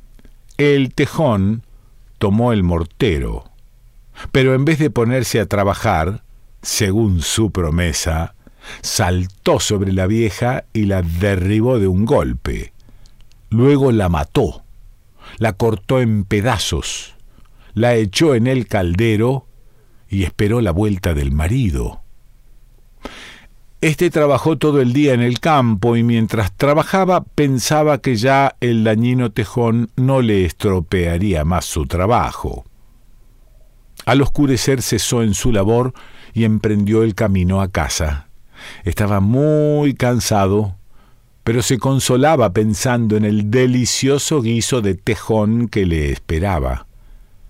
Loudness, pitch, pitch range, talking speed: -16 LUFS, 115 Hz, 100-125 Hz, 120 wpm